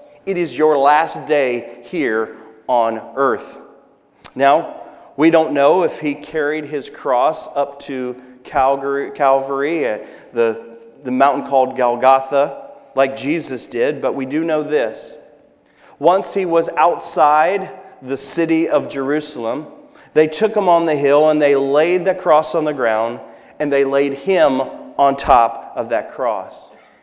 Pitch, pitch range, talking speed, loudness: 140 Hz, 135-155 Hz, 145 wpm, -17 LUFS